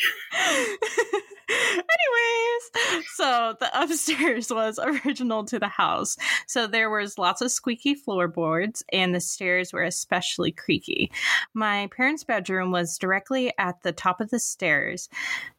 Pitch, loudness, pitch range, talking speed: 235 Hz, -24 LUFS, 190-320 Hz, 125 wpm